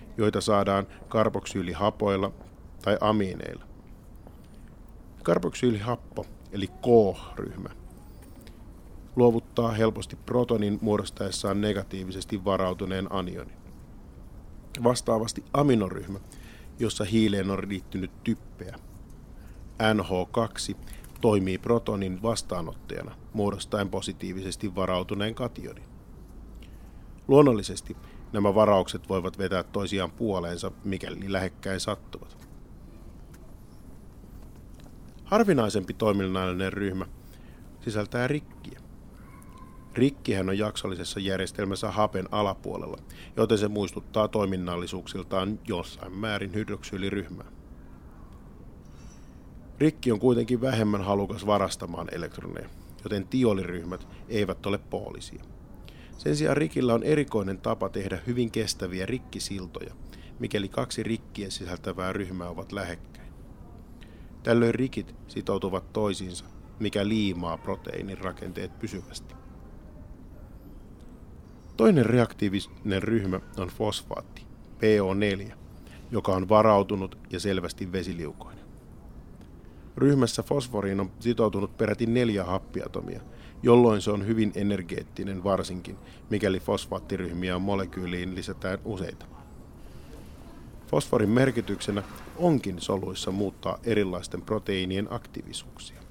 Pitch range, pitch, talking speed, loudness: 95-110 Hz, 100 Hz, 85 wpm, -28 LUFS